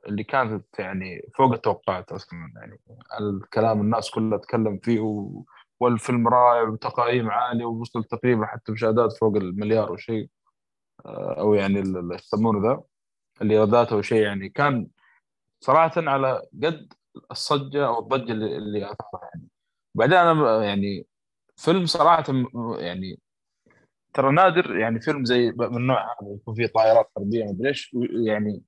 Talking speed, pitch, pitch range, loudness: 130 wpm, 115 Hz, 105-125 Hz, -23 LUFS